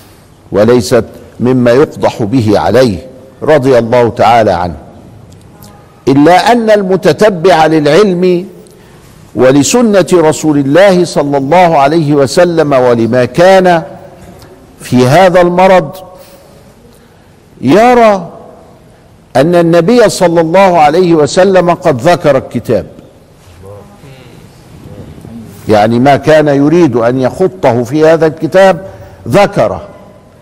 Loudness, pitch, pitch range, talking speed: -7 LUFS, 160 Hz, 125-185 Hz, 90 wpm